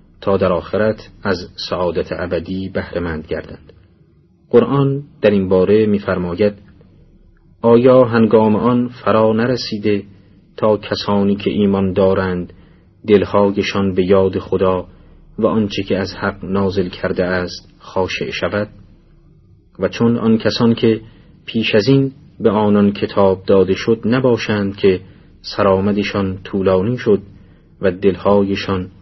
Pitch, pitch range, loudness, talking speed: 100 Hz, 95-110 Hz, -16 LUFS, 120 wpm